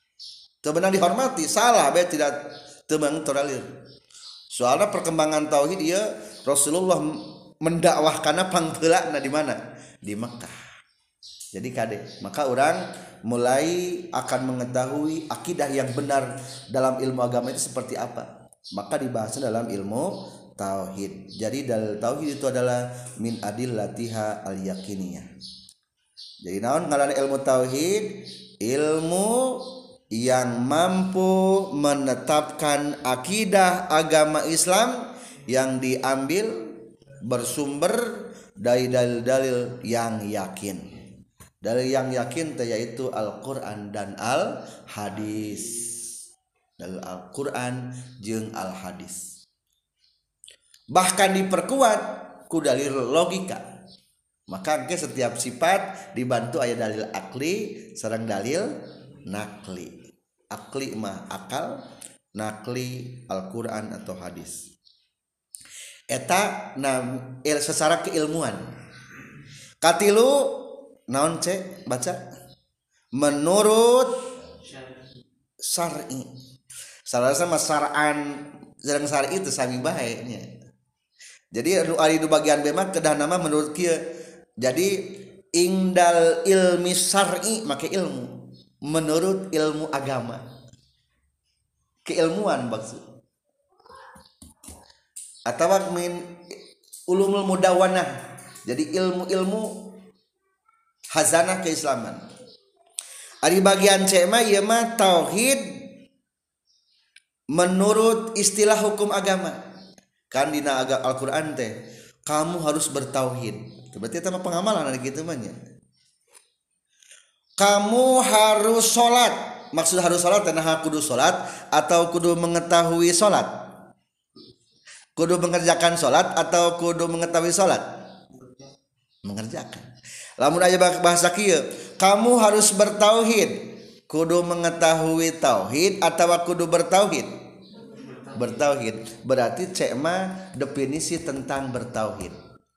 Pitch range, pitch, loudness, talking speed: 125-185 Hz, 155 Hz, -23 LUFS, 90 wpm